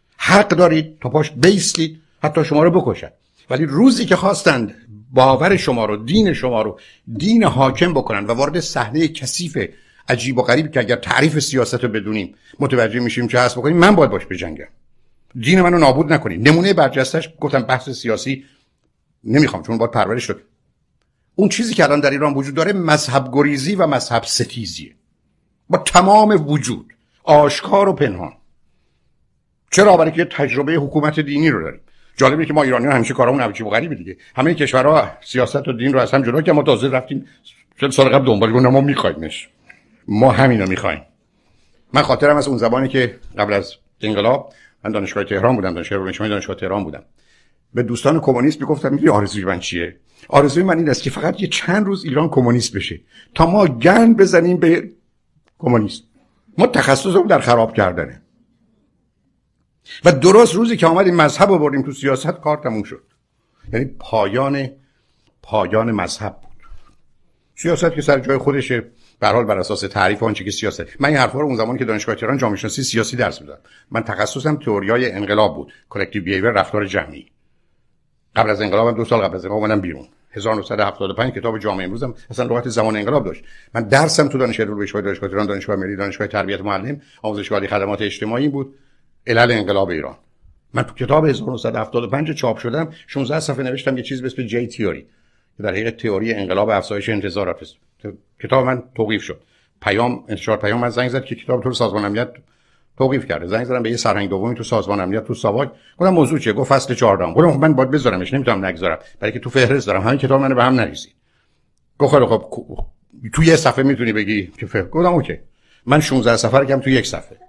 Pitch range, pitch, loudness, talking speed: 110-150 Hz, 130 Hz, -16 LUFS, 180 wpm